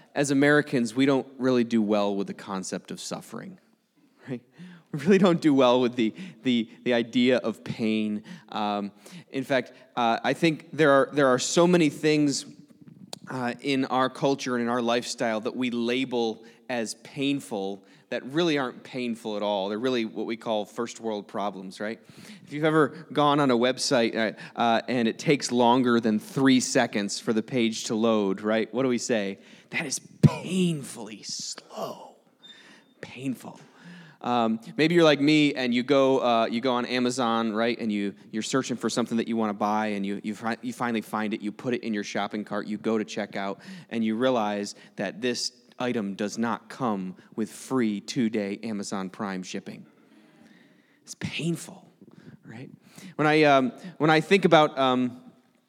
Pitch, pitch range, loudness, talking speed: 120 Hz, 110-140 Hz, -26 LUFS, 180 wpm